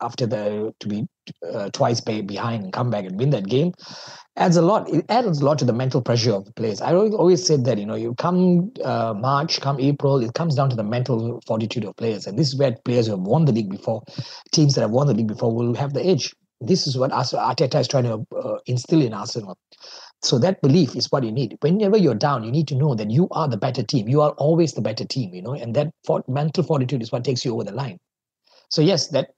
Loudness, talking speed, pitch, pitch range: -21 LUFS, 255 wpm, 135 Hz, 115-155 Hz